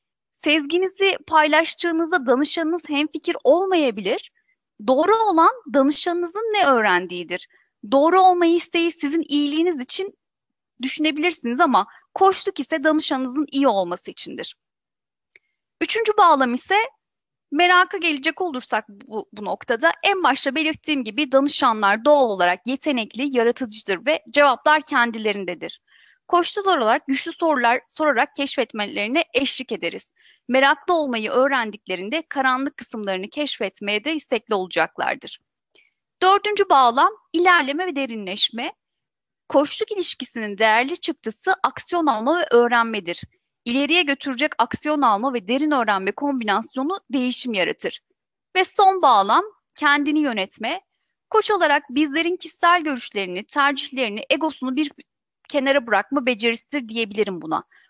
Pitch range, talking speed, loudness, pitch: 240-340 Hz, 110 wpm, -20 LUFS, 290 Hz